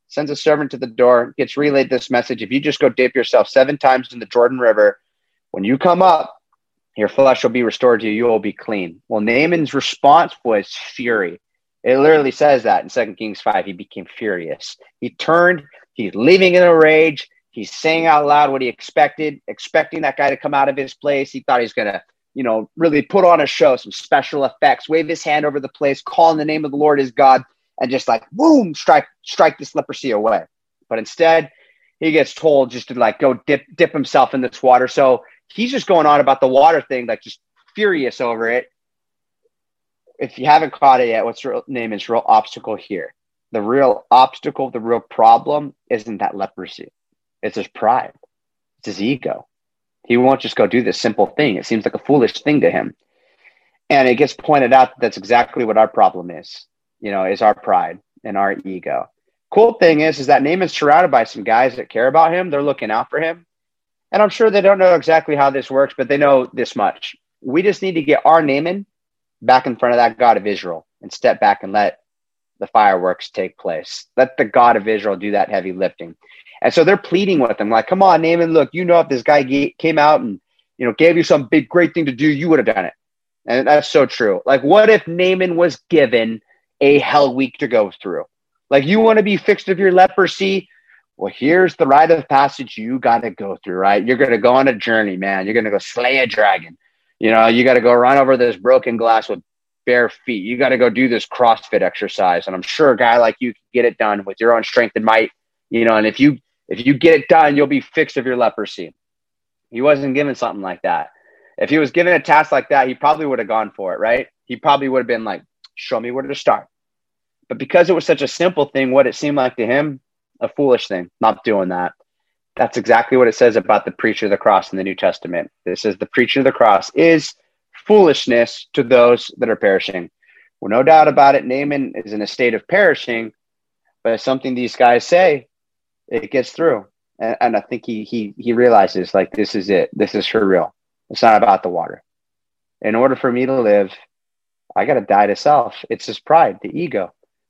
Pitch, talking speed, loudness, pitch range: 135 Hz, 225 wpm, -15 LUFS, 120-160 Hz